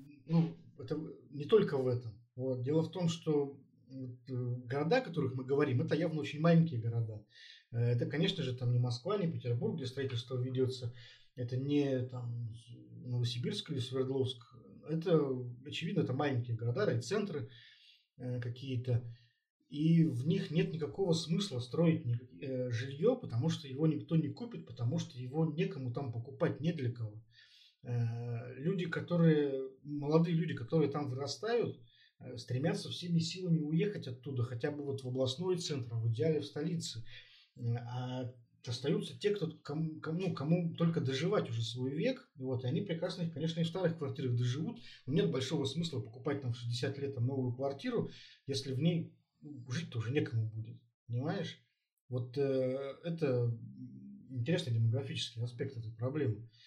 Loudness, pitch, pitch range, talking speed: -36 LUFS, 135 Hz, 125-160 Hz, 150 wpm